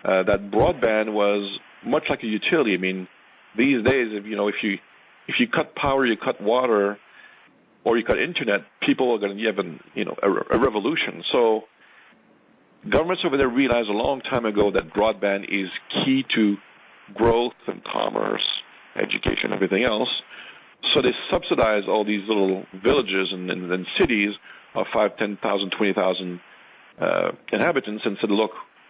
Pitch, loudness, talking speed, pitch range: 105 Hz, -23 LUFS, 165 wpm, 95-110 Hz